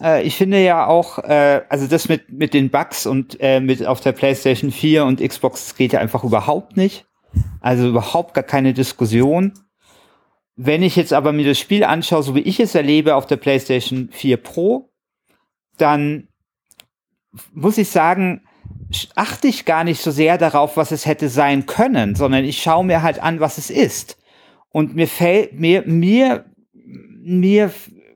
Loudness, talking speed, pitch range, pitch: -16 LUFS, 165 wpm, 135-175 Hz, 155 Hz